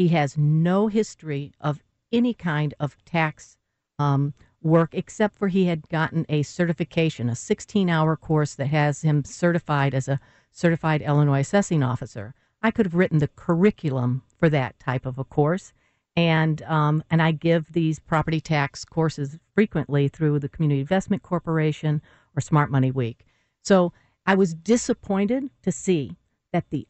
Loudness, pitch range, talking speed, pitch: -23 LUFS, 140-175 Hz, 155 wpm, 155 Hz